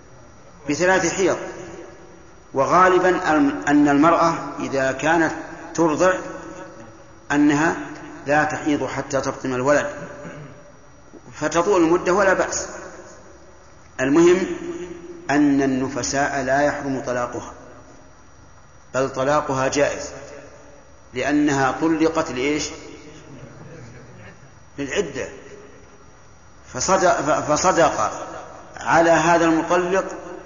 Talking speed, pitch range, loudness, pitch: 70 wpm, 135-175 Hz, -20 LUFS, 150 Hz